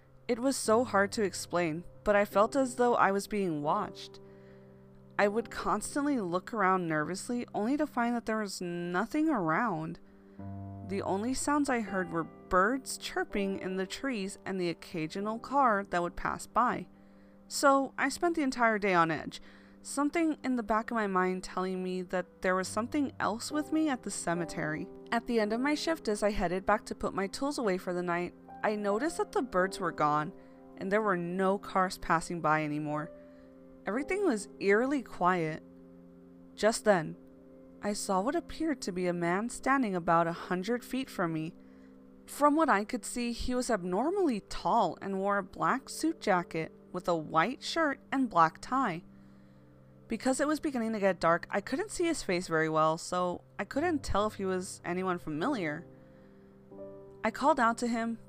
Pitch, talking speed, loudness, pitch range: 195 Hz, 185 wpm, -31 LUFS, 160-240 Hz